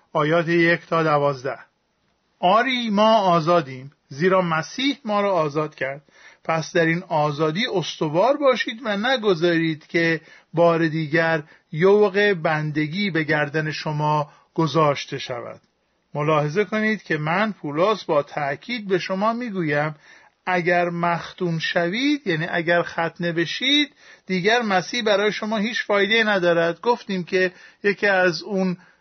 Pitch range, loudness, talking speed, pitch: 160-205 Hz, -21 LUFS, 125 wpm, 175 Hz